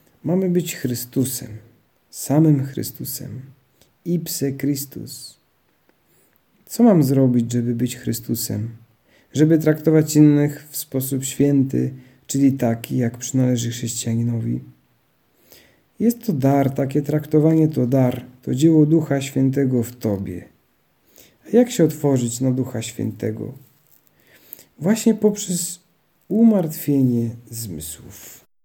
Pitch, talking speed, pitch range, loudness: 135 Hz, 105 wpm, 120-155 Hz, -20 LUFS